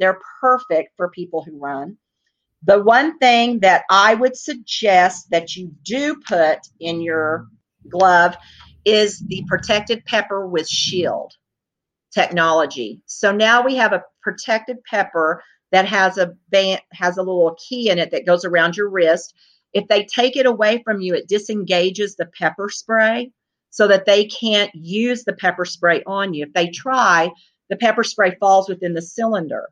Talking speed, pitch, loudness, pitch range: 165 wpm, 195 Hz, -17 LUFS, 175-220 Hz